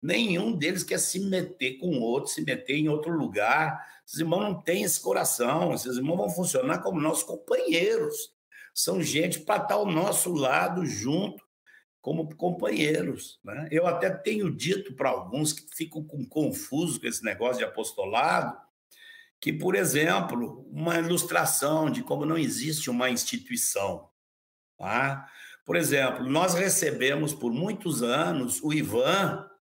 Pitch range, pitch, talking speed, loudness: 150-195 Hz, 165 Hz, 145 wpm, -27 LUFS